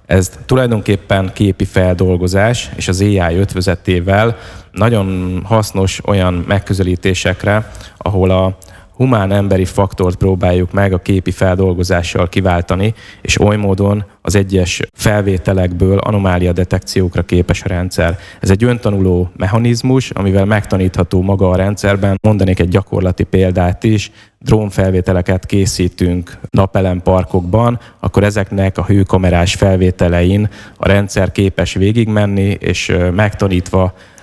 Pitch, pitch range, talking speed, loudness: 95 Hz, 90-100 Hz, 110 wpm, -13 LUFS